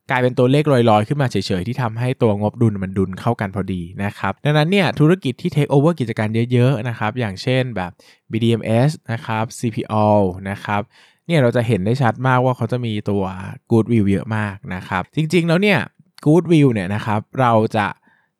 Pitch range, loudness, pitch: 105-130 Hz, -18 LUFS, 115 Hz